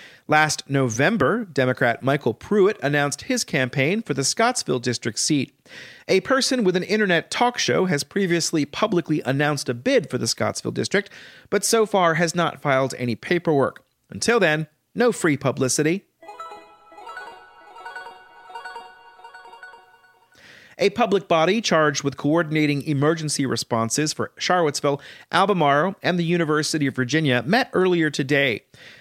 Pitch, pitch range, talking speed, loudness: 155 Hz, 135-185 Hz, 130 wpm, -21 LUFS